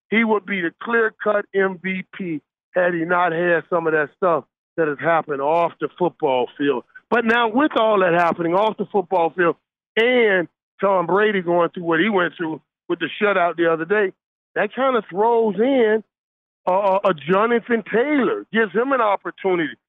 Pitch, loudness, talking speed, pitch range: 190 Hz, -20 LUFS, 180 wpm, 170-220 Hz